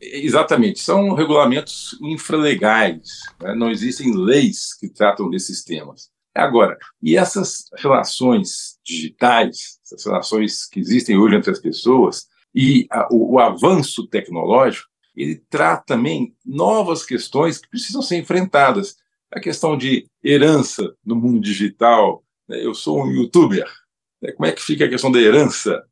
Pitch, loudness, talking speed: 160 Hz, -17 LUFS, 140 wpm